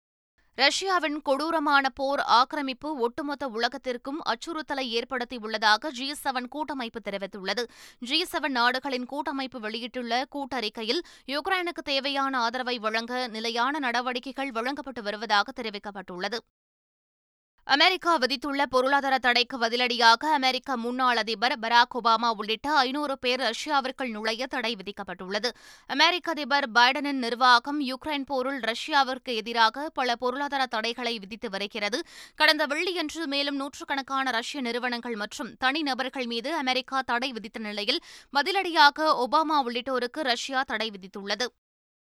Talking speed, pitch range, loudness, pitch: 105 wpm, 235-285 Hz, -26 LUFS, 255 Hz